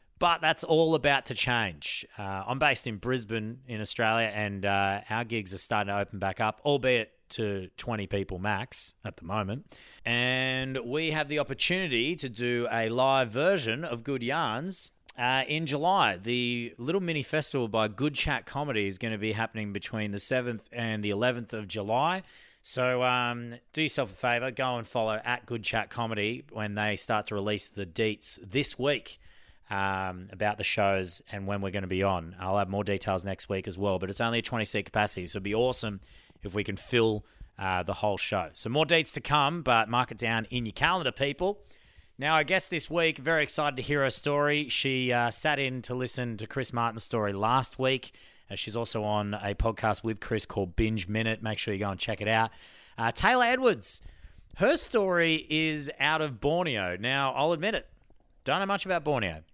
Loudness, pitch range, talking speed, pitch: -29 LUFS, 105-140 Hz, 200 wpm, 115 Hz